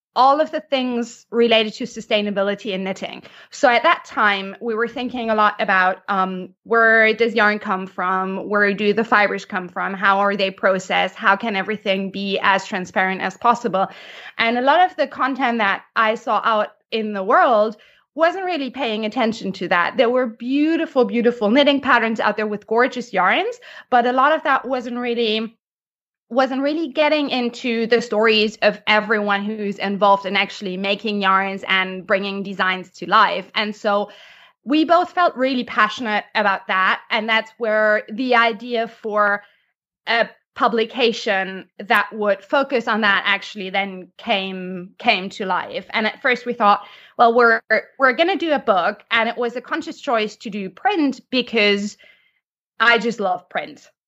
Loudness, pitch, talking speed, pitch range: -19 LUFS, 220 Hz, 170 wpm, 200-245 Hz